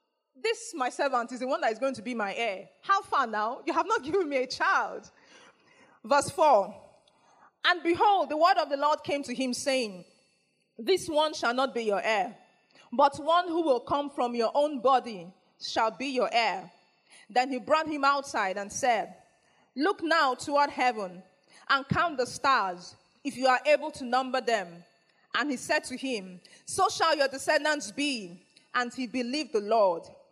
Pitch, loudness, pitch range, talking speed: 270 Hz, -28 LUFS, 240-305 Hz, 185 wpm